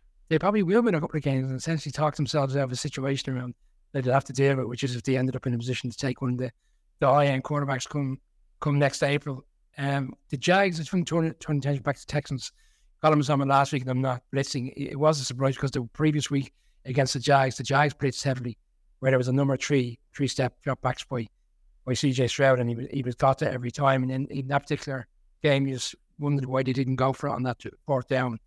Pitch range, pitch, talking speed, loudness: 130-145 Hz, 135 Hz, 255 wpm, -26 LUFS